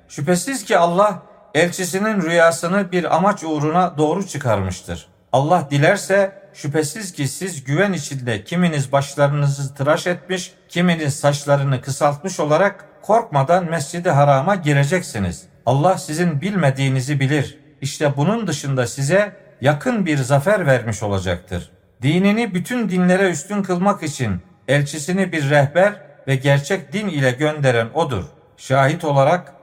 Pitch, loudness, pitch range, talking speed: 155 Hz, -18 LUFS, 140-185 Hz, 120 wpm